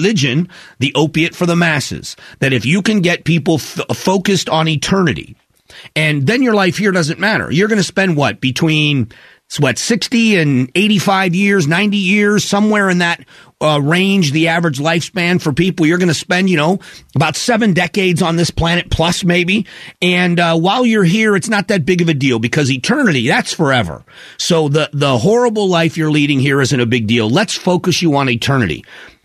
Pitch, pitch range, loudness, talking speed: 170 Hz, 150-195 Hz, -13 LUFS, 190 wpm